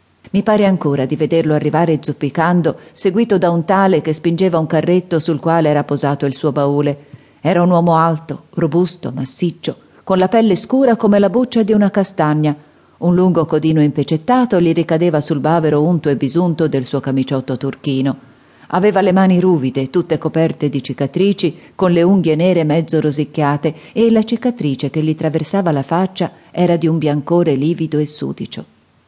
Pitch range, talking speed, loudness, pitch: 150-180 Hz, 170 wpm, -15 LUFS, 165 Hz